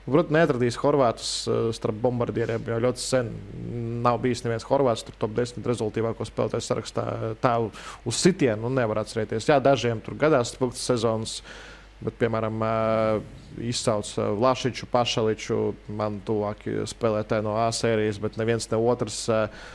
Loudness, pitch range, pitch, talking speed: -25 LUFS, 110-125 Hz, 115 Hz, 130 wpm